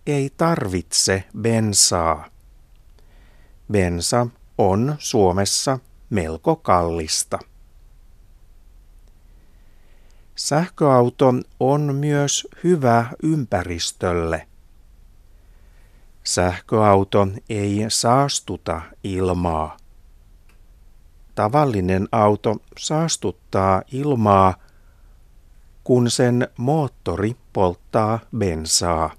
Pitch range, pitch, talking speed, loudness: 85-120 Hz, 100 Hz, 55 wpm, -20 LUFS